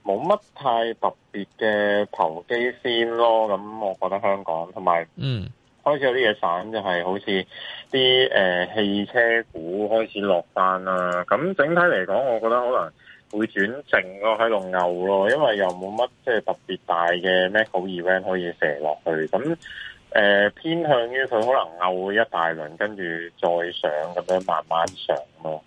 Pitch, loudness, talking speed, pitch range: 95 Hz, -22 LUFS, 250 characters per minute, 90-115 Hz